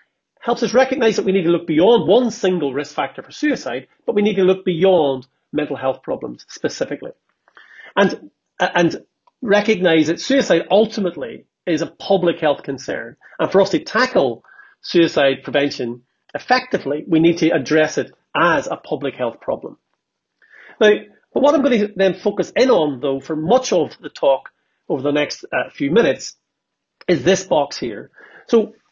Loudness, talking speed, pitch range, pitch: -18 LUFS, 170 wpm, 150-210 Hz, 180 Hz